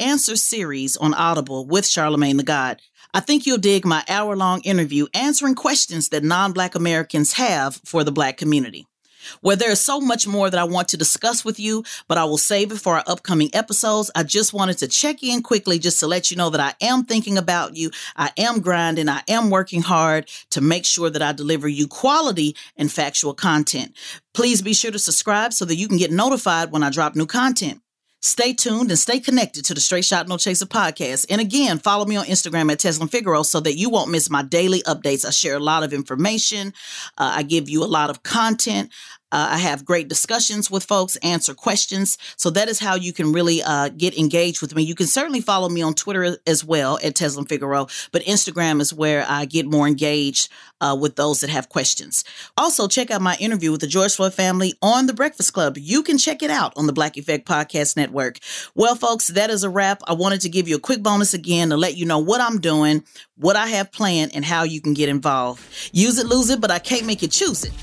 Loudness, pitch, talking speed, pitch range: -19 LUFS, 175 Hz, 230 wpm, 155-210 Hz